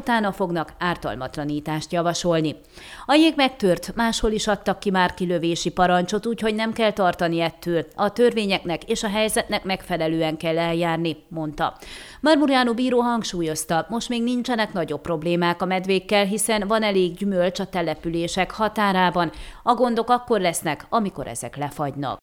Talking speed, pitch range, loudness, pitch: 140 wpm, 165-220 Hz, -22 LUFS, 185 Hz